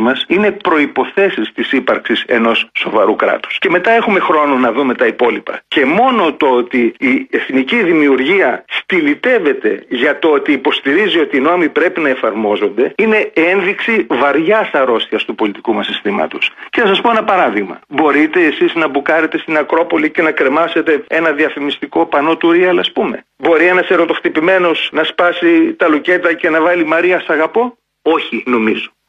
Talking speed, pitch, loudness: 160 wpm, 180 Hz, -13 LUFS